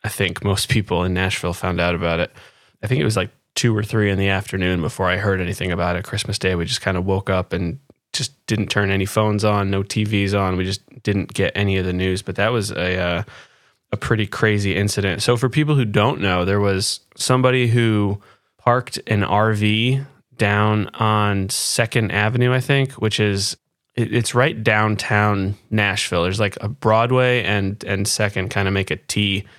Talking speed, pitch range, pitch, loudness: 200 wpm, 95-110 Hz, 100 Hz, -19 LUFS